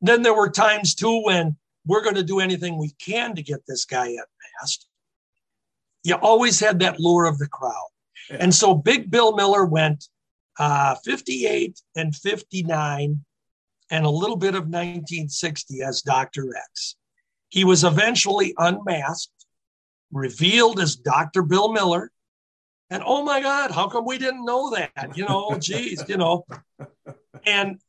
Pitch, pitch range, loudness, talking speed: 175 Hz, 145-210 Hz, -21 LUFS, 150 wpm